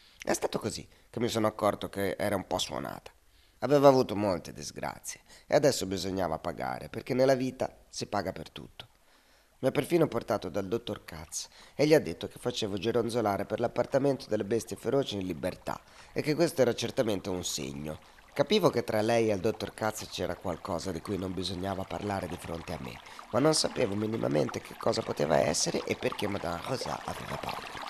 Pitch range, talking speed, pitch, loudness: 90-120 Hz, 190 wpm, 100 Hz, -31 LUFS